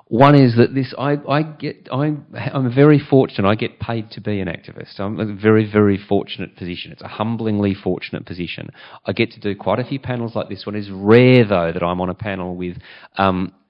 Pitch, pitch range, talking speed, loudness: 105 Hz, 95-125 Hz, 220 wpm, -18 LUFS